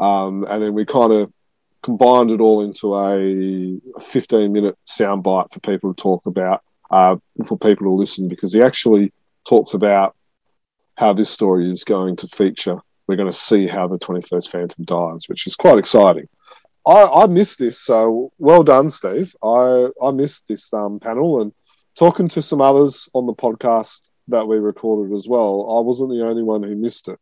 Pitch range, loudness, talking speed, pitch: 95-120 Hz, -16 LUFS, 185 wpm, 105 Hz